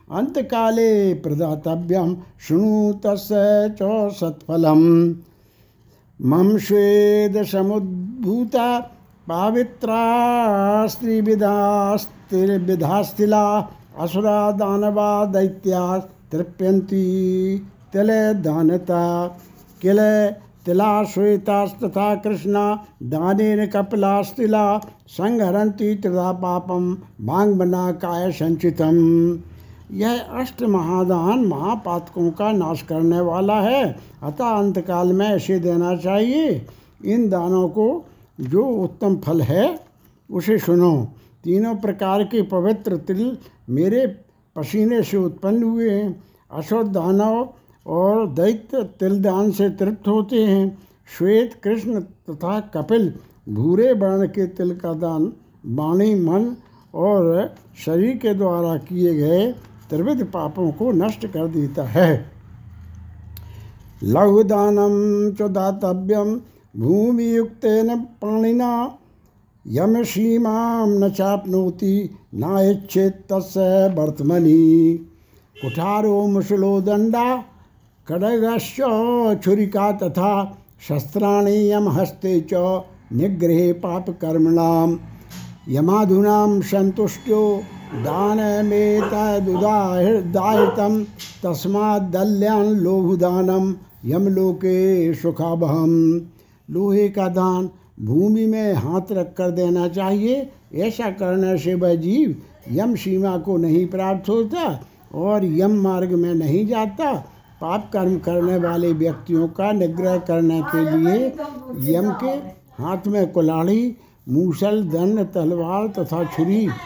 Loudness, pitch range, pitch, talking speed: -19 LUFS, 170-210 Hz, 190 Hz, 90 wpm